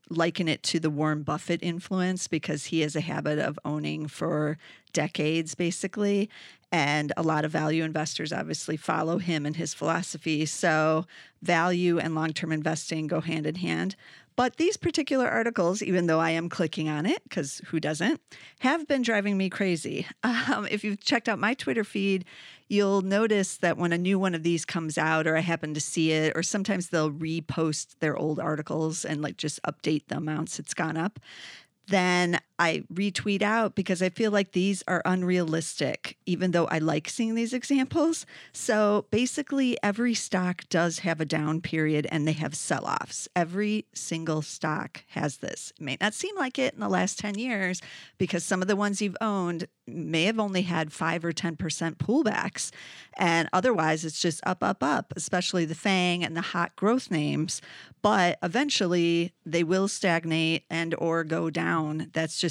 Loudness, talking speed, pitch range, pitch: -27 LUFS, 180 wpm, 160-200 Hz, 170 Hz